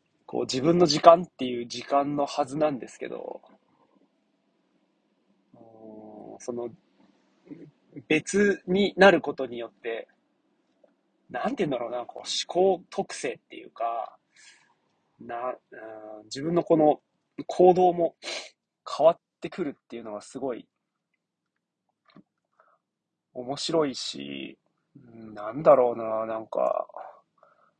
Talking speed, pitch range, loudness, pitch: 200 characters per minute, 115-170 Hz, -25 LUFS, 140 Hz